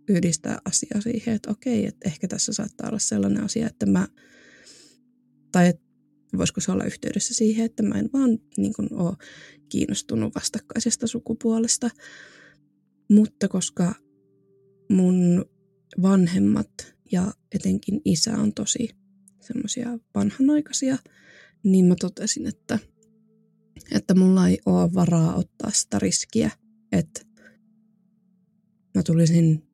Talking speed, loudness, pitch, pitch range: 115 wpm, -23 LUFS, 205 Hz, 180-230 Hz